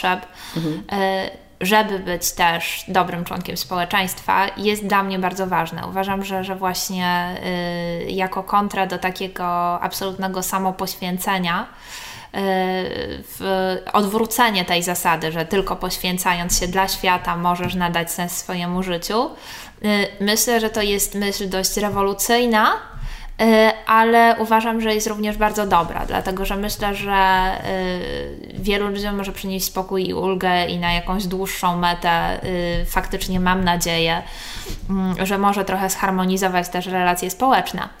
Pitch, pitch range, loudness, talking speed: 190 Hz, 180-200 Hz, -20 LUFS, 125 wpm